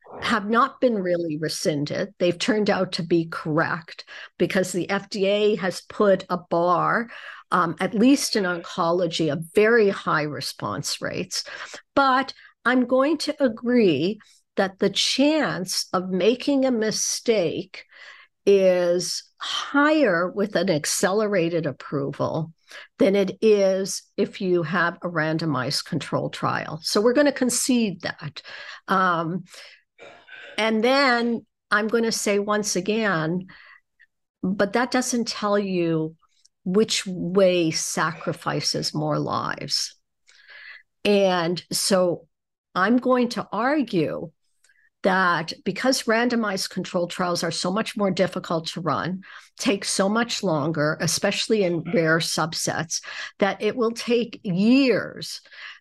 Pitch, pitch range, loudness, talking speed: 195 Hz, 175-235 Hz, -23 LUFS, 120 wpm